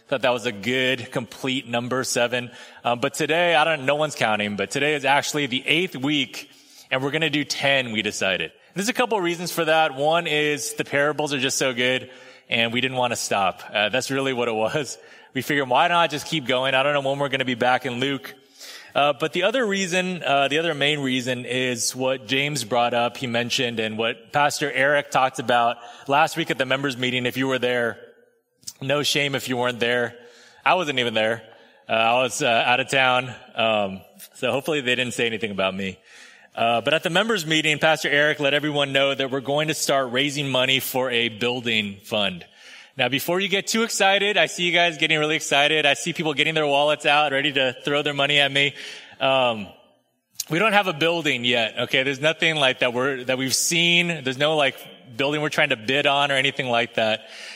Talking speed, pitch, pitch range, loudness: 230 wpm, 135 Hz, 125-150 Hz, -21 LUFS